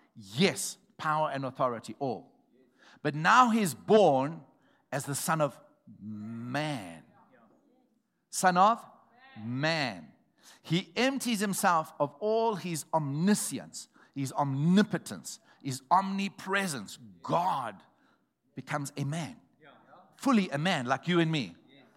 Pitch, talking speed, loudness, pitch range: 160 Hz, 105 wpm, -29 LUFS, 140-195 Hz